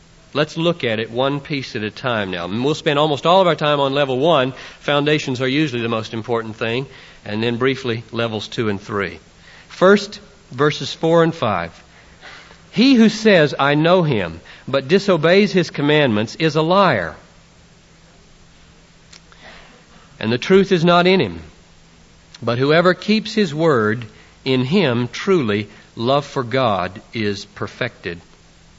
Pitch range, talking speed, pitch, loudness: 110-165 Hz, 150 wpm, 135 Hz, -18 LUFS